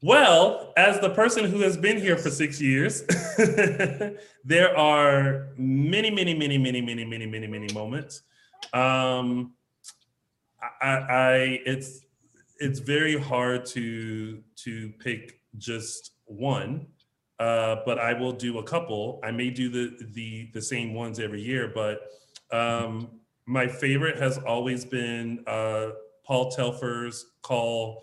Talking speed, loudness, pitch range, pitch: 135 wpm, -25 LUFS, 115-140 Hz, 125 Hz